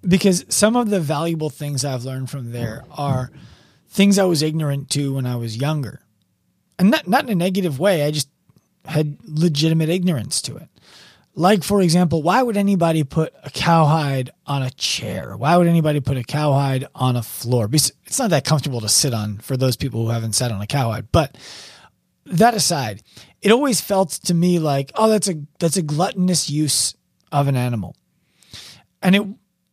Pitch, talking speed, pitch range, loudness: 150 Hz, 190 wpm, 130-180 Hz, -19 LUFS